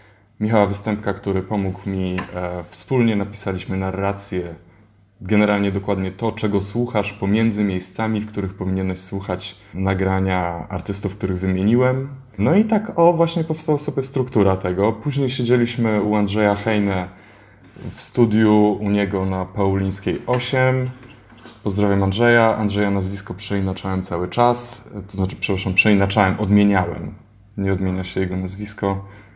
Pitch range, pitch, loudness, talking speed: 95-110 Hz, 100 Hz, -20 LUFS, 125 wpm